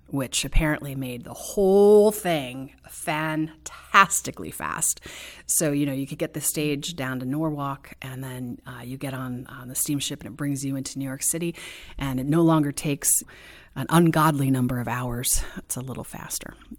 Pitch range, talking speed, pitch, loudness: 130-155 Hz, 180 wpm, 140 Hz, -24 LUFS